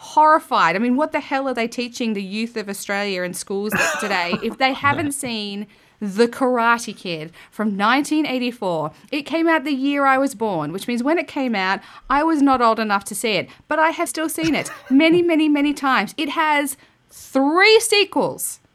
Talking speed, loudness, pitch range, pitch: 195 wpm, -19 LUFS, 210-305 Hz, 260 Hz